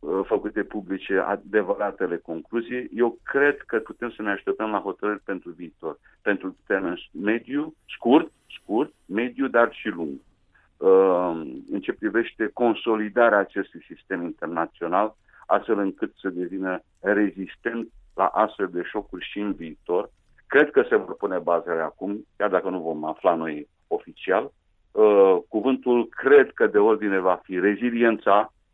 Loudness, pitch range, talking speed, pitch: -24 LUFS, 95-145 Hz, 140 wpm, 115 Hz